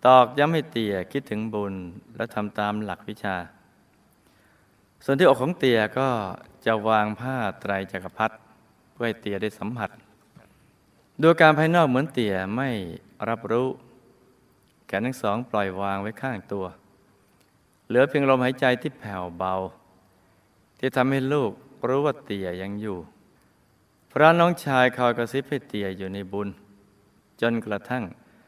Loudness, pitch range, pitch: -24 LUFS, 100-130 Hz, 110 Hz